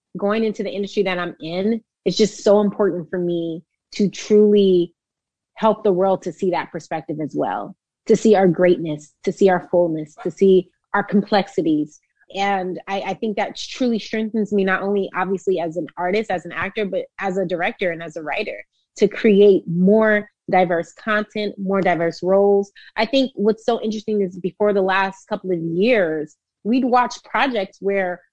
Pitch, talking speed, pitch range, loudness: 195 Hz, 180 wpm, 180-210 Hz, -20 LUFS